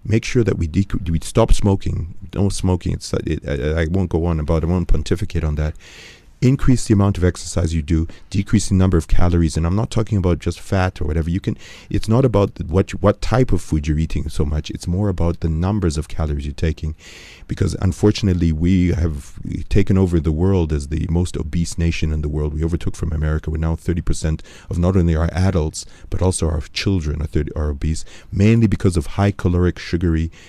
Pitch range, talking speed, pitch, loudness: 80-95 Hz, 220 wpm, 85 Hz, -20 LUFS